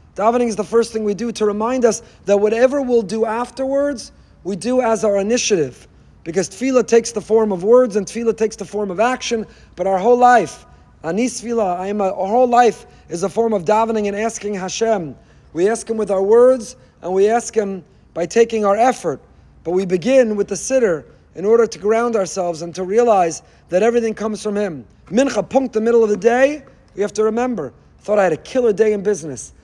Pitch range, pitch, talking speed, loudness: 195-235 Hz, 220 Hz, 210 wpm, -17 LUFS